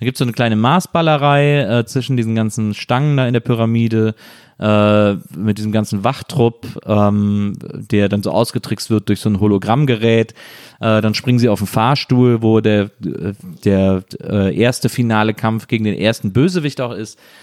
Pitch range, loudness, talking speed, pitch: 105-125 Hz, -16 LUFS, 175 wpm, 110 Hz